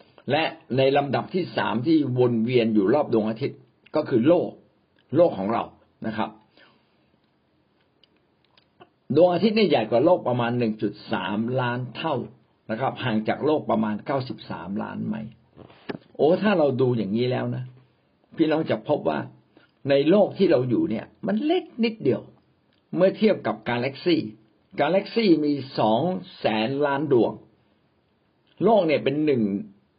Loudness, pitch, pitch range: -23 LUFS, 130 Hz, 110-160 Hz